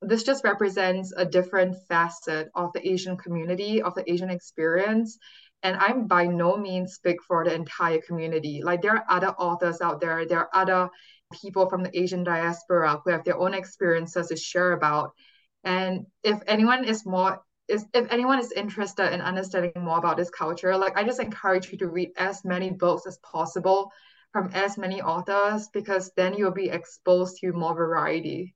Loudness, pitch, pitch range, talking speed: -25 LUFS, 185 Hz, 175-195 Hz, 185 wpm